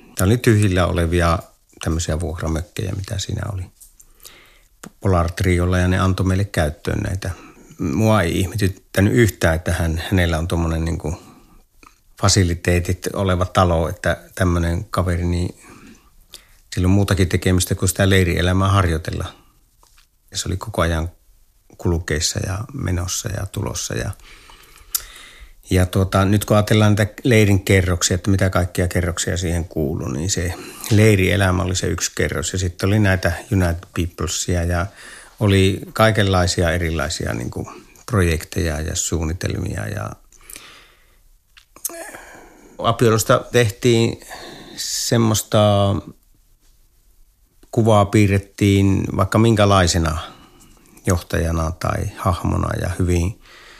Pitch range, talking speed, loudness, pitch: 85-105 Hz, 115 wpm, -19 LUFS, 95 Hz